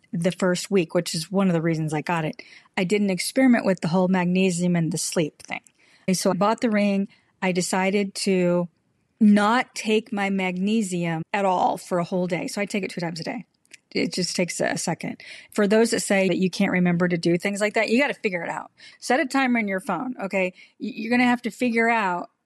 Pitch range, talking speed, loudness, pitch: 180-220 Hz, 230 wpm, -23 LUFS, 195 Hz